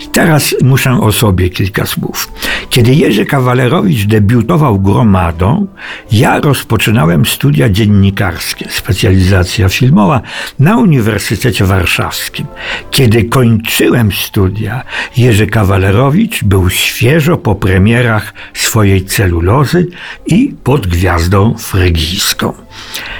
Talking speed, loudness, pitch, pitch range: 90 wpm, -10 LUFS, 115 Hz, 95-135 Hz